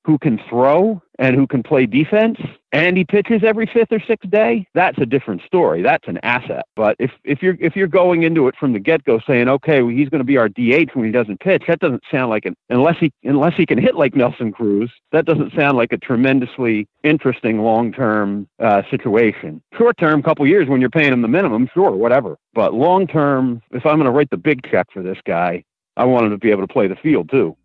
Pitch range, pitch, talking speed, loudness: 120-170 Hz, 140 Hz, 240 wpm, -16 LUFS